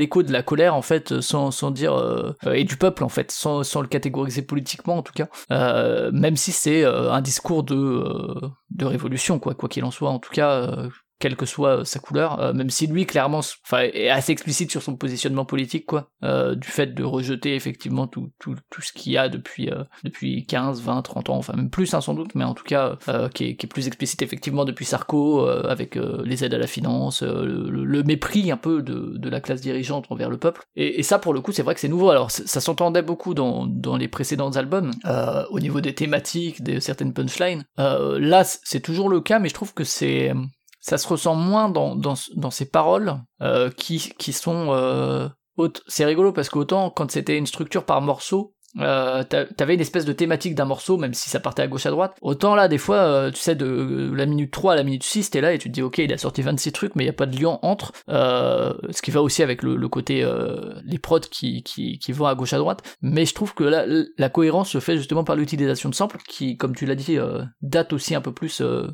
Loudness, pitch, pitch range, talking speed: -22 LUFS, 145 Hz, 130-165 Hz, 250 wpm